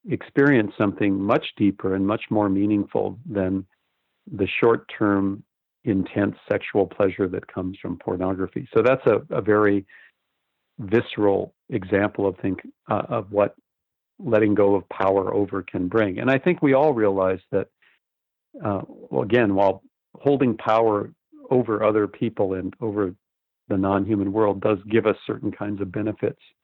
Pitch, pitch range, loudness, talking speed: 100 Hz, 95-110 Hz, -23 LUFS, 145 wpm